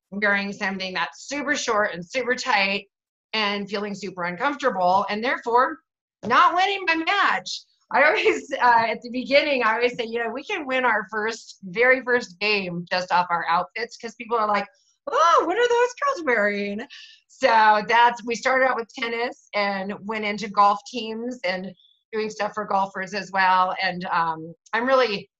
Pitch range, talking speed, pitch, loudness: 200-255 Hz, 175 wpm, 220 Hz, -22 LUFS